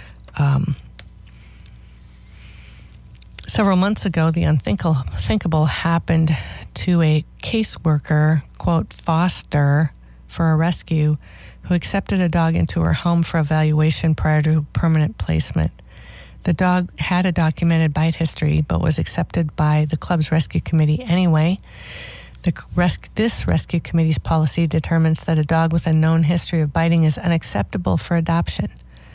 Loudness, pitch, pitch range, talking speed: -19 LUFS, 160 Hz, 150-170 Hz, 130 wpm